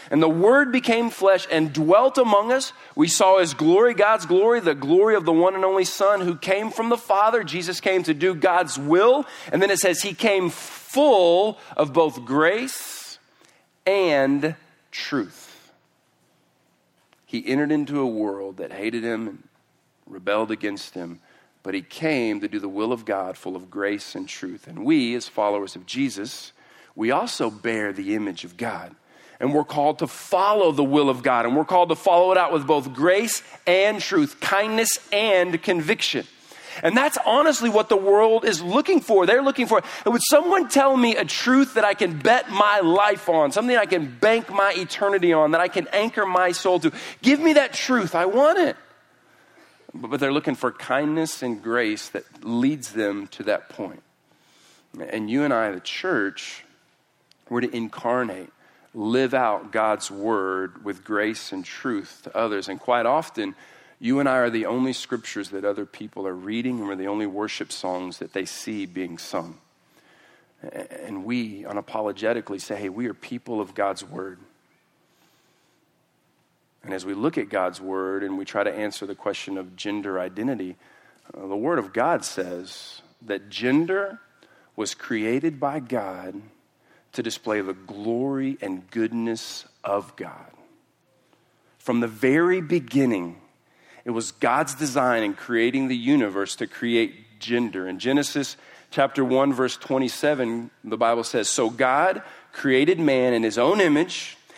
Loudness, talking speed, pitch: -22 LUFS, 170 wpm, 150 Hz